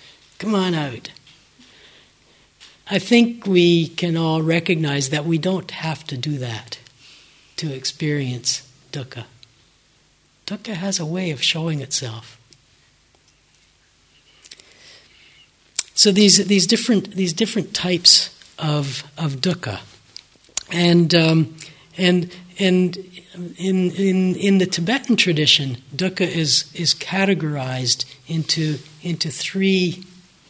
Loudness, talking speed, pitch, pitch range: -19 LUFS, 105 wpm, 165 Hz, 140-185 Hz